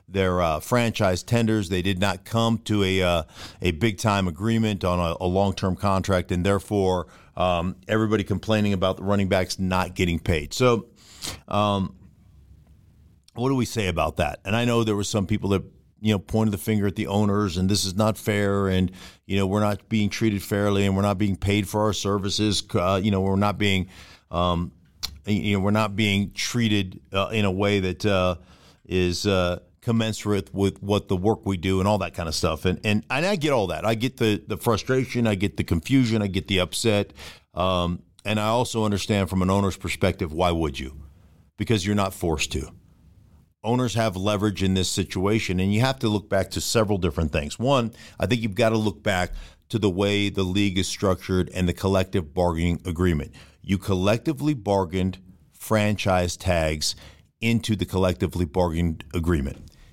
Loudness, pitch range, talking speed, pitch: -24 LUFS, 90-105 Hz, 195 wpm, 100 Hz